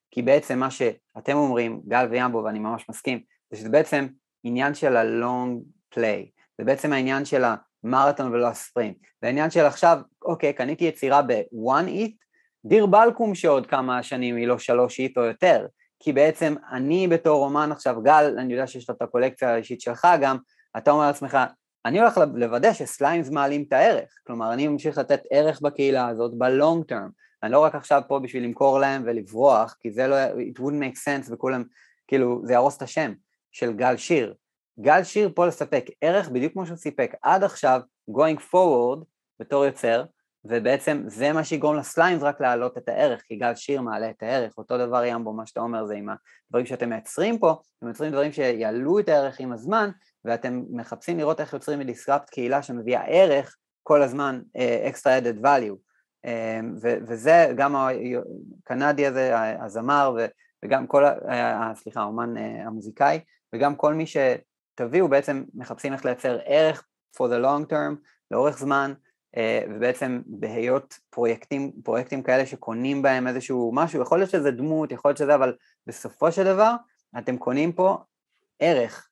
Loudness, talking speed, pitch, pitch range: -23 LUFS, 170 wpm, 135 Hz, 120-150 Hz